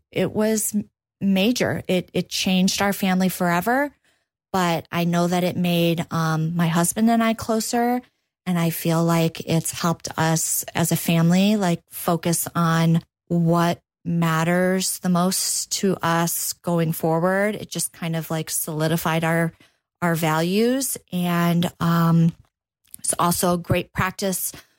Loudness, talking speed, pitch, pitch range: -22 LUFS, 140 wpm, 175 Hz, 165-185 Hz